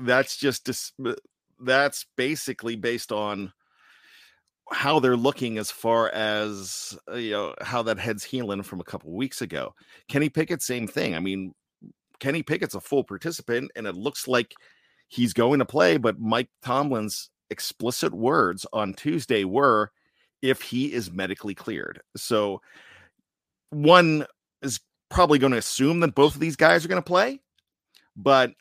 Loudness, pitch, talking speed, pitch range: -24 LUFS, 125 Hz, 155 wpm, 105-145 Hz